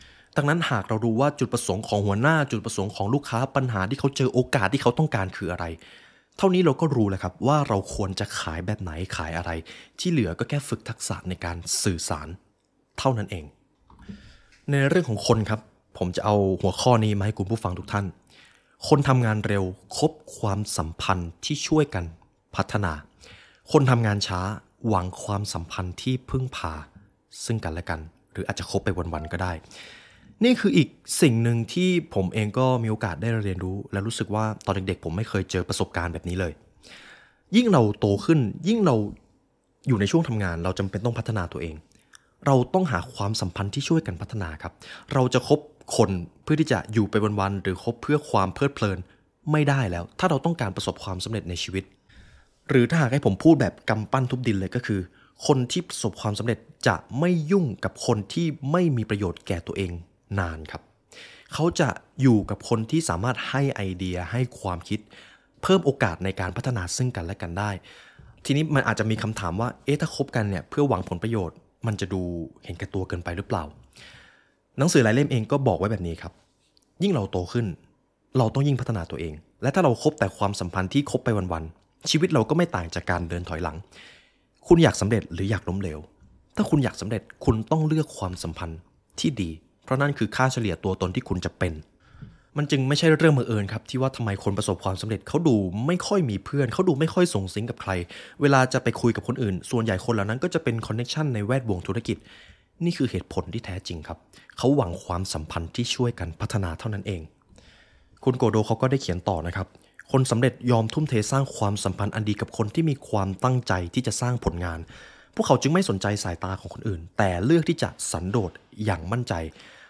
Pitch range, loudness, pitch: 95-130 Hz, -25 LUFS, 110 Hz